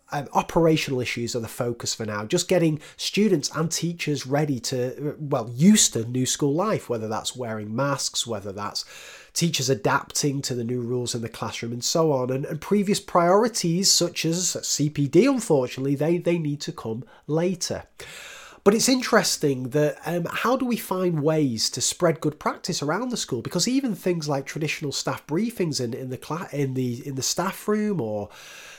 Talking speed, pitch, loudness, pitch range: 185 wpm, 150 Hz, -24 LUFS, 125-175 Hz